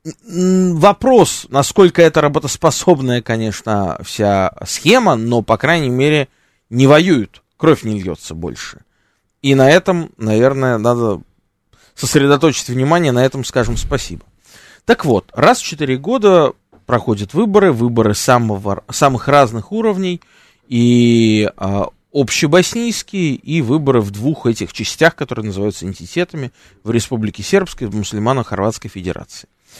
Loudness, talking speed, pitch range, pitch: -14 LUFS, 120 wpm, 110-160 Hz, 125 Hz